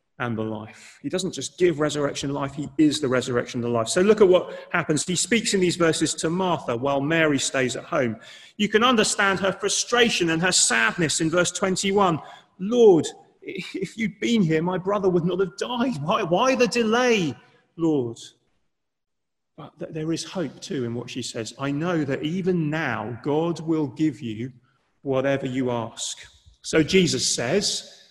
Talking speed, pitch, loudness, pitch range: 175 wpm, 165 Hz, -23 LUFS, 135-195 Hz